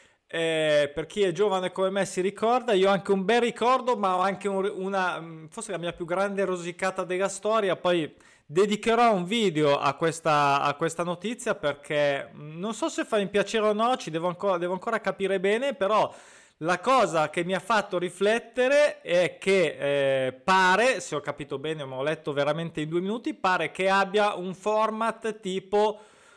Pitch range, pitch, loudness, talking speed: 165-215 Hz, 190 Hz, -26 LUFS, 185 wpm